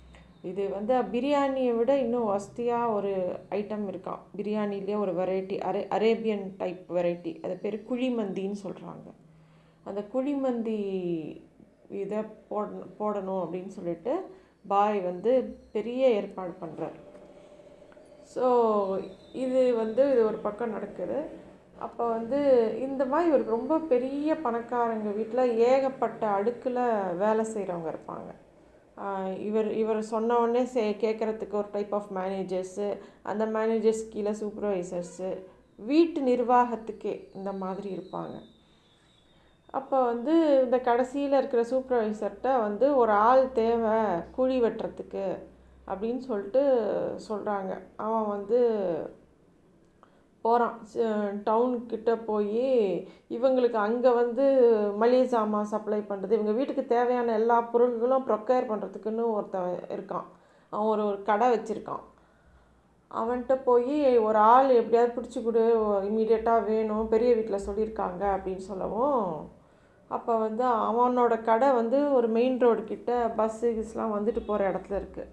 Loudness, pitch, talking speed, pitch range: -27 LUFS, 220 Hz, 110 wpm, 205-245 Hz